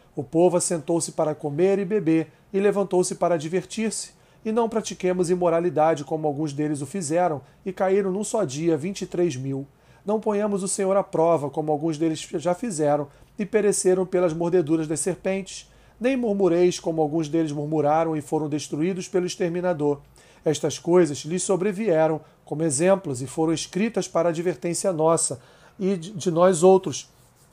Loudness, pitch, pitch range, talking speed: -23 LUFS, 170 Hz, 155-190 Hz, 160 wpm